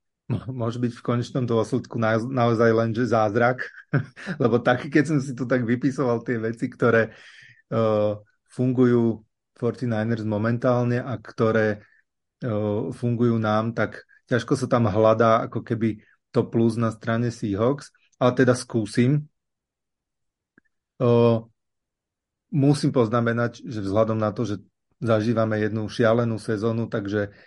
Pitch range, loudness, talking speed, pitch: 110-125 Hz, -23 LUFS, 125 wpm, 115 Hz